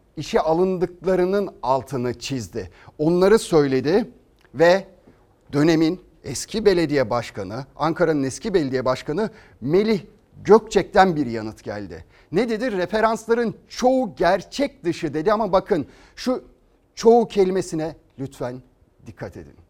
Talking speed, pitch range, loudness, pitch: 105 wpm, 130-200 Hz, -21 LUFS, 165 Hz